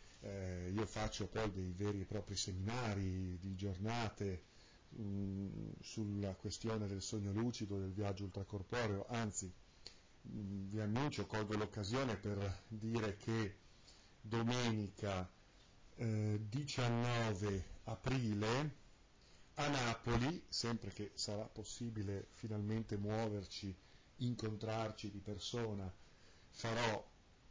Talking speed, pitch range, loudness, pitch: 100 wpm, 100-115 Hz, -43 LUFS, 105 Hz